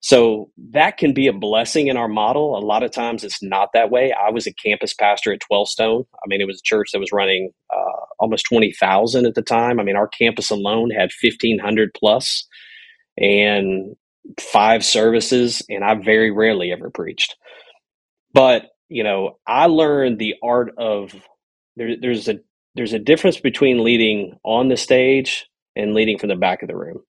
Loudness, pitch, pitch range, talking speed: -17 LUFS, 110 Hz, 105-125 Hz, 190 wpm